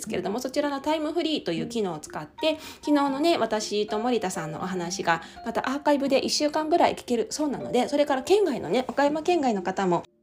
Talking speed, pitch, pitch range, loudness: 430 characters per minute, 265 Hz, 205-305 Hz, -26 LUFS